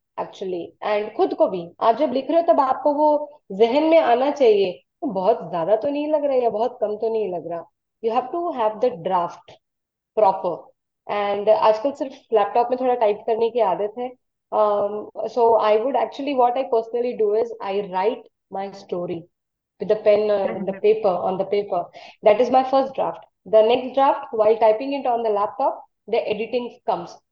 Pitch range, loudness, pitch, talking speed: 205-265 Hz, -21 LUFS, 225 Hz, 180 wpm